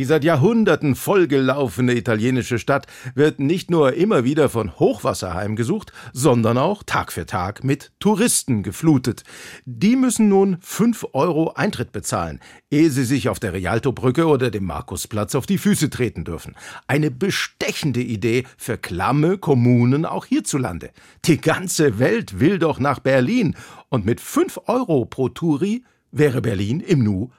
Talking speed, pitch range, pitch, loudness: 150 wpm, 120-165 Hz, 135 Hz, -19 LUFS